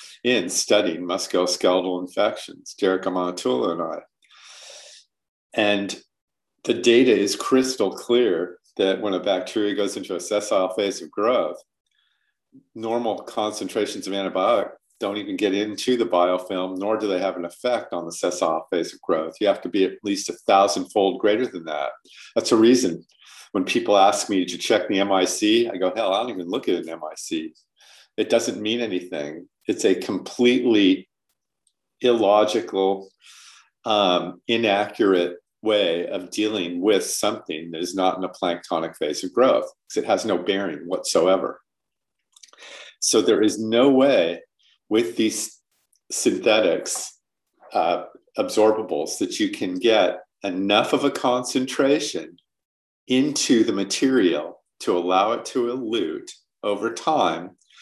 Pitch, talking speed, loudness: 110 Hz, 145 wpm, -22 LUFS